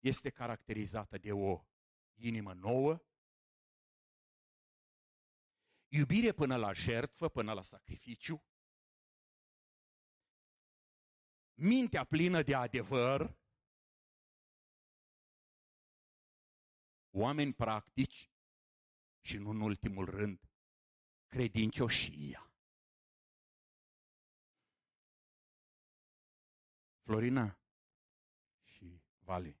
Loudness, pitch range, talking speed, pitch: -37 LUFS, 95-135 Hz, 55 wpm, 110 Hz